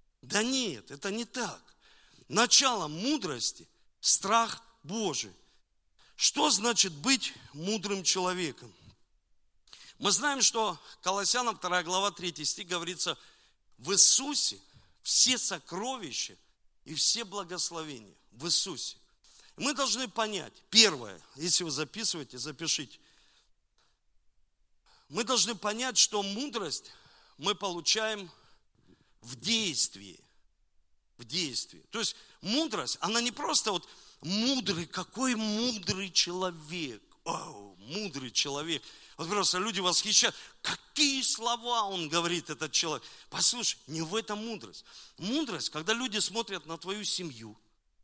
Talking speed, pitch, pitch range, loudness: 110 wpm, 200 Hz, 165-230 Hz, -28 LUFS